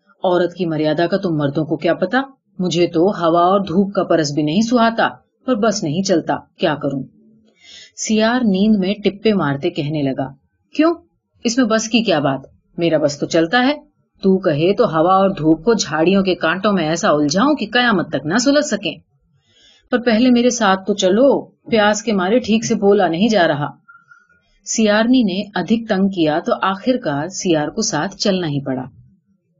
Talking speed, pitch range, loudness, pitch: 185 wpm, 160-225 Hz, -17 LUFS, 190 Hz